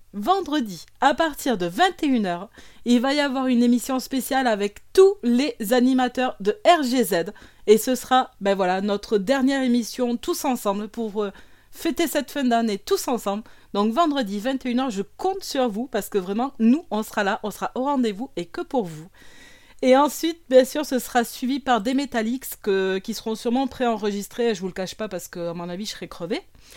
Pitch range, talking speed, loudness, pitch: 210-270 Hz, 195 wpm, -23 LUFS, 245 Hz